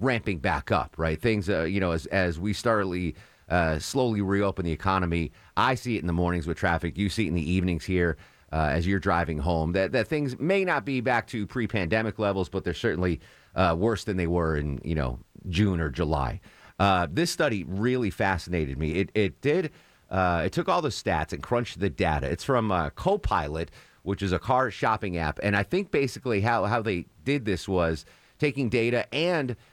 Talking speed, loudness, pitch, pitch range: 210 wpm, -27 LUFS, 95 Hz, 85-110 Hz